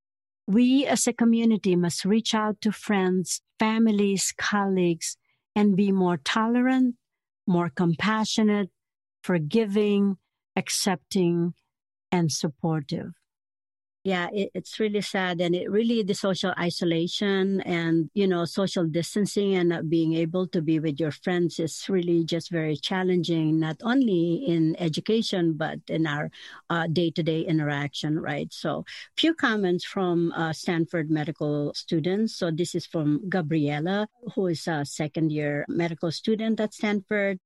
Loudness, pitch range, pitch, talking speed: -25 LUFS, 165-205 Hz, 180 Hz, 135 wpm